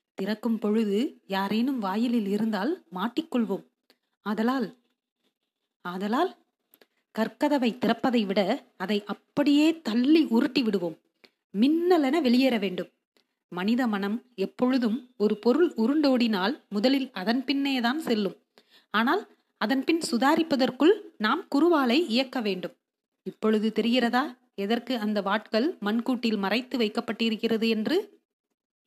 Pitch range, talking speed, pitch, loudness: 210-270 Hz, 95 wpm, 235 Hz, -26 LUFS